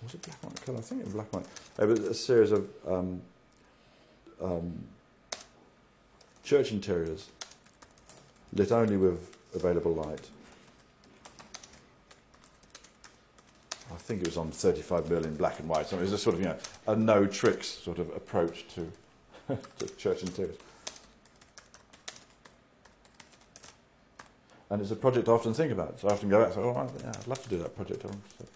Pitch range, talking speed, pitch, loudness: 90-110 Hz, 170 wpm, 100 Hz, -31 LUFS